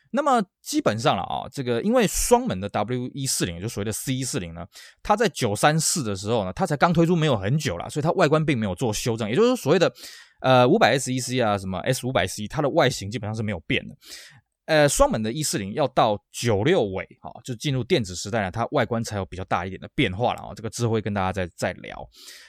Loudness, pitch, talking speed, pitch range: -23 LUFS, 125 Hz, 370 characters per minute, 105-155 Hz